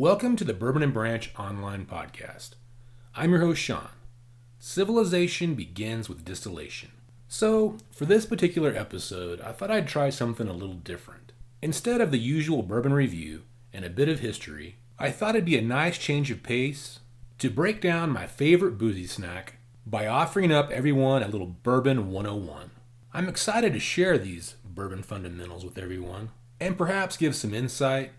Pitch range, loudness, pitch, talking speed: 110-155 Hz, -27 LUFS, 120 Hz, 165 wpm